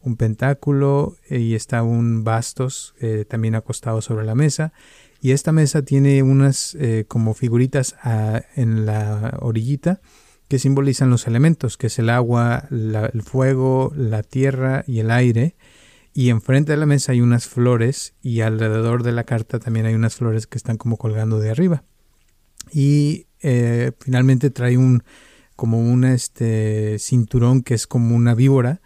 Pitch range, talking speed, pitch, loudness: 115-135 Hz, 160 wpm, 120 Hz, -19 LUFS